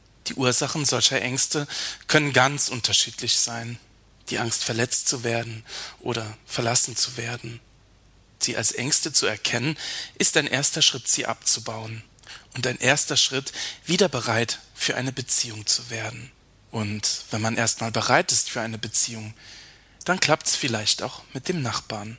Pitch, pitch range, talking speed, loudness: 120 Hz, 110-130 Hz, 150 wpm, -21 LUFS